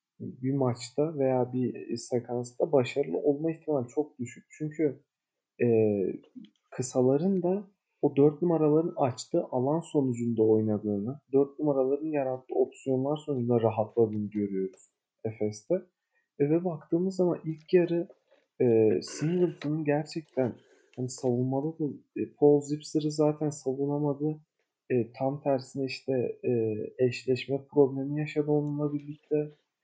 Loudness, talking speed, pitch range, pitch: -29 LUFS, 110 wpm, 125-155 Hz, 140 Hz